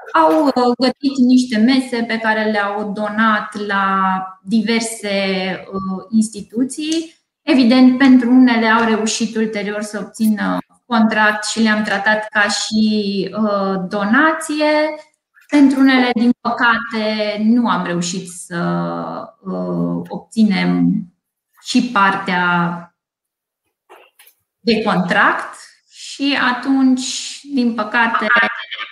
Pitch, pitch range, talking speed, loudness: 220 Hz, 200-250 Hz, 90 wpm, -16 LUFS